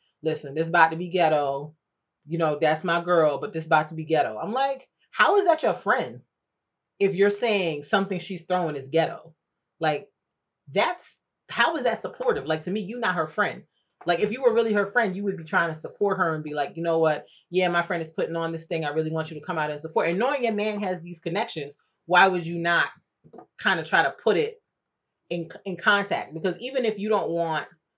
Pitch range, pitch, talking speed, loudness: 160-205 Hz, 170 Hz, 235 wpm, -25 LUFS